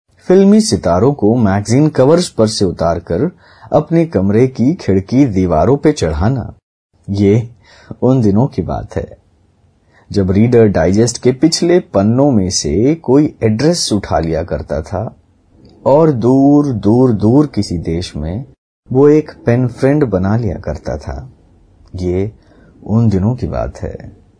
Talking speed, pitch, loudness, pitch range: 140 wpm, 110 Hz, -13 LUFS, 95-135 Hz